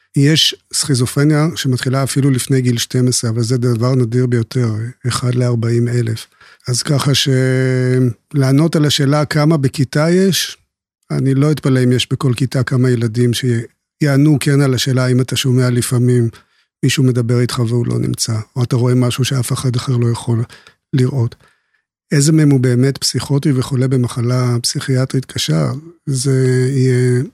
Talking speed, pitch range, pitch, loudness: 145 wpm, 125-140 Hz, 130 Hz, -15 LUFS